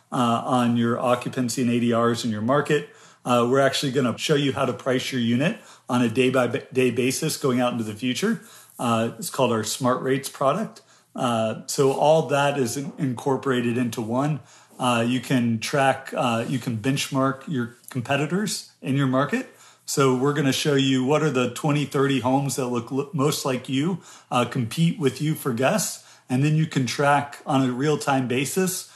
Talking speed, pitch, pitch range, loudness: 195 wpm, 135 Hz, 125-145 Hz, -23 LUFS